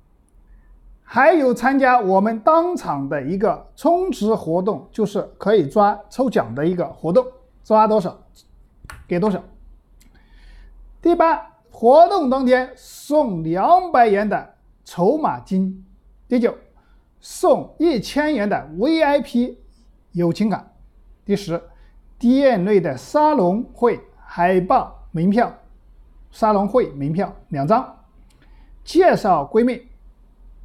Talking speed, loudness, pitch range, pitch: 165 characters per minute, -18 LUFS, 190-265 Hz, 220 Hz